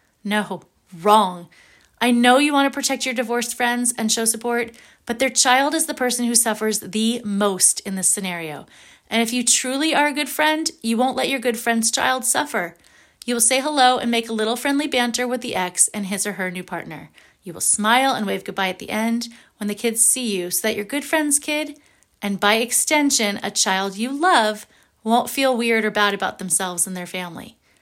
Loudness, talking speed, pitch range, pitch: -19 LUFS, 215 wpm, 205-255 Hz, 235 Hz